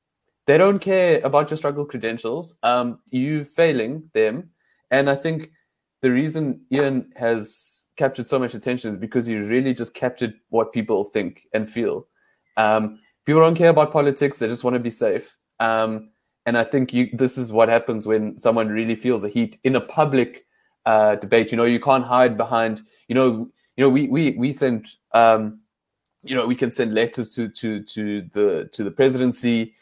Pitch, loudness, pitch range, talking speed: 125 Hz, -21 LUFS, 115-135 Hz, 185 wpm